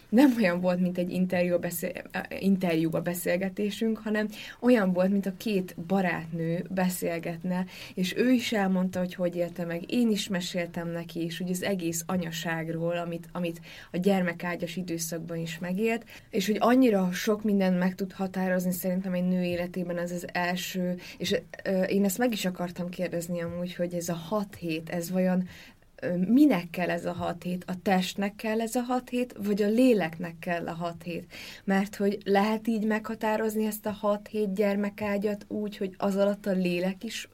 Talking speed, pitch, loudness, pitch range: 175 wpm, 185 Hz, -29 LUFS, 175-205 Hz